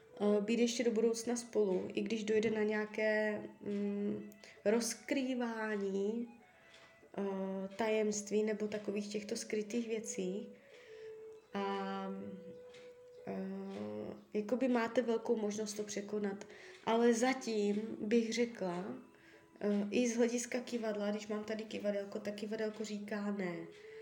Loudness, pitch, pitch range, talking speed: -37 LUFS, 215 Hz, 205-235 Hz, 100 wpm